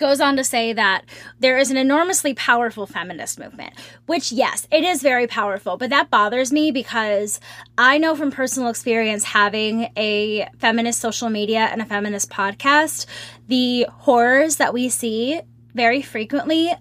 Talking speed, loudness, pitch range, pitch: 155 wpm, -19 LUFS, 220-280 Hz, 240 Hz